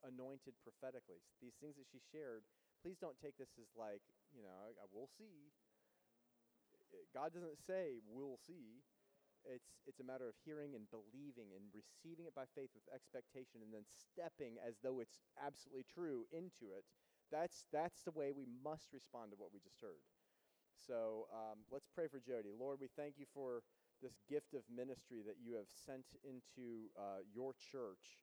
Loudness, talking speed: -53 LUFS, 180 wpm